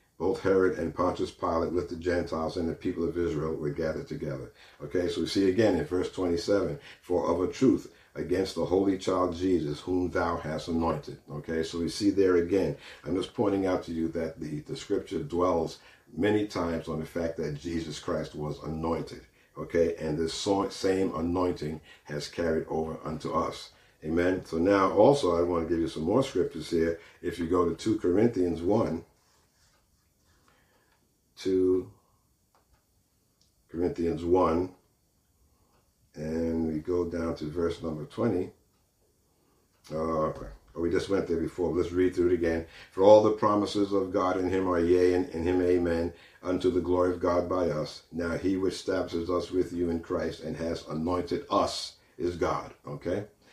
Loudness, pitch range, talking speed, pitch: -29 LUFS, 80-90 Hz, 175 wpm, 85 Hz